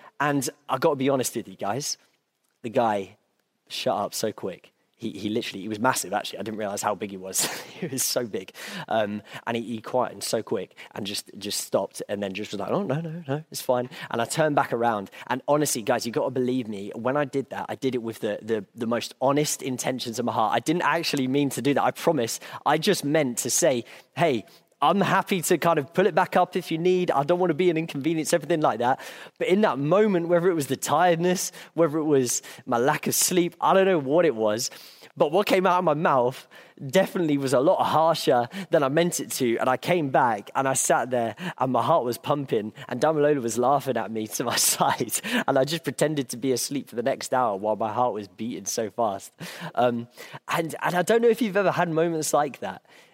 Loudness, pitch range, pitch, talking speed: -25 LUFS, 120-170 Hz, 140 Hz, 240 wpm